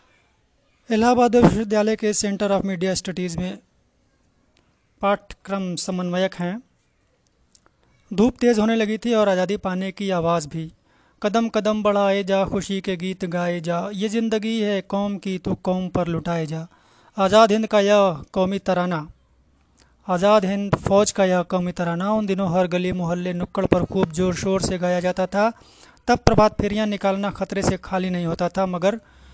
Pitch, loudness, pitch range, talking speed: 190 Hz, -21 LUFS, 180-210 Hz, 160 wpm